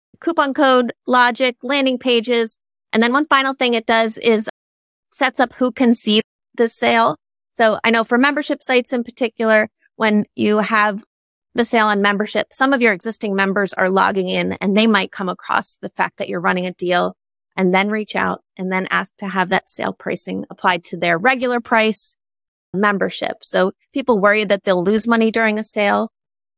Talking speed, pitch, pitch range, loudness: 185 wpm, 225 Hz, 205-250 Hz, -17 LUFS